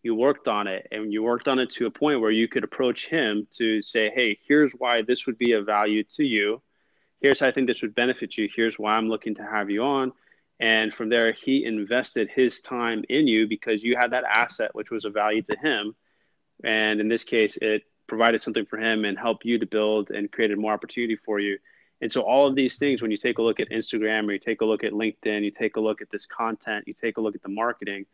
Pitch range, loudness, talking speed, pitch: 105-125 Hz, -24 LUFS, 255 wpm, 110 Hz